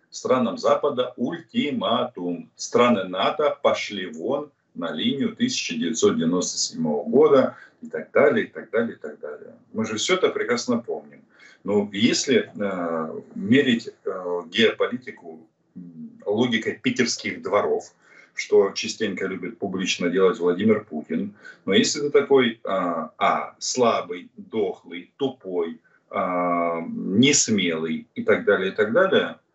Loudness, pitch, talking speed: -23 LUFS, 220 Hz, 120 wpm